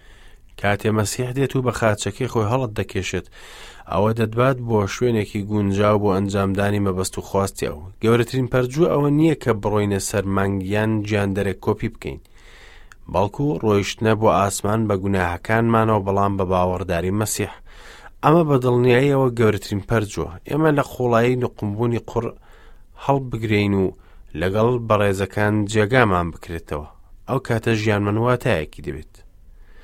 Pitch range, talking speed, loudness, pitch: 95-120 Hz, 120 wpm, -20 LUFS, 105 Hz